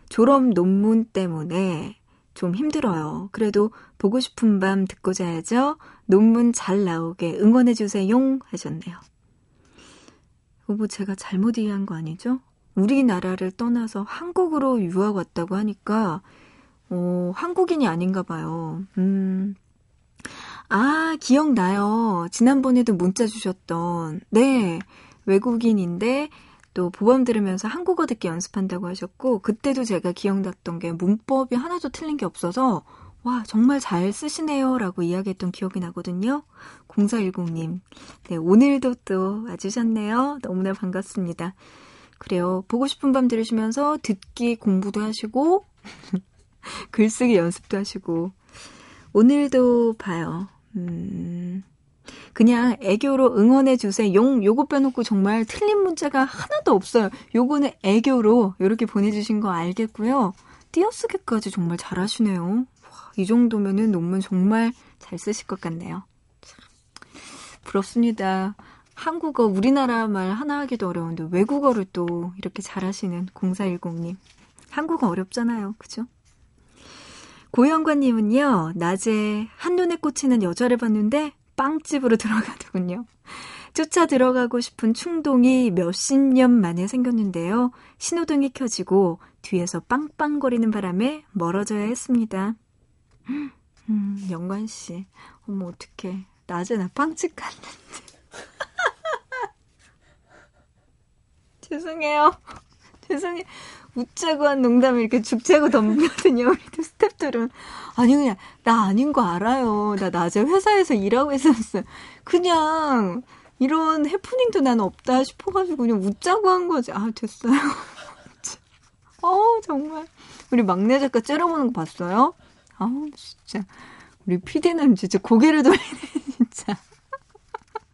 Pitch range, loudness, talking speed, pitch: 190-270 Hz, -22 LUFS, 265 characters per minute, 225 Hz